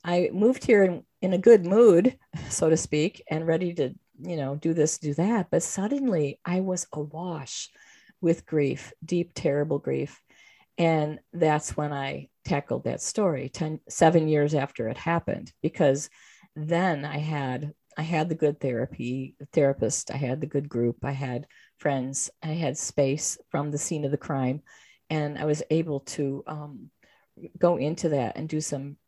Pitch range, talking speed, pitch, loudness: 140-170 Hz, 170 wpm, 155 Hz, -26 LUFS